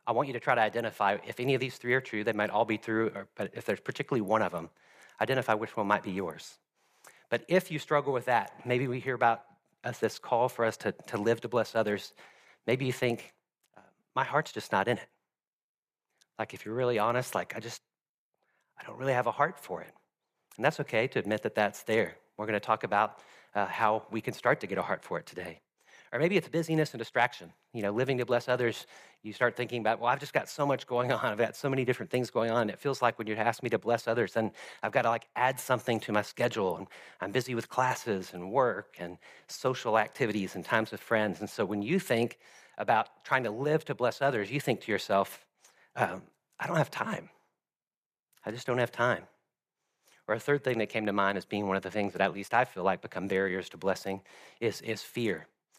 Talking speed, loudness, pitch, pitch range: 240 wpm, -31 LUFS, 115 Hz, 105-125 Hz